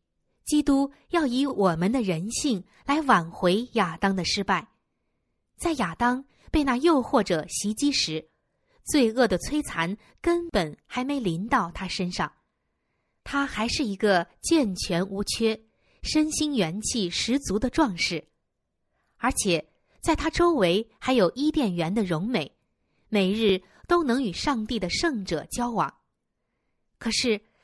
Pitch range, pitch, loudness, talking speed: 190-280 Hz, 225 Hz, -25 LUFS, 190 characters per minute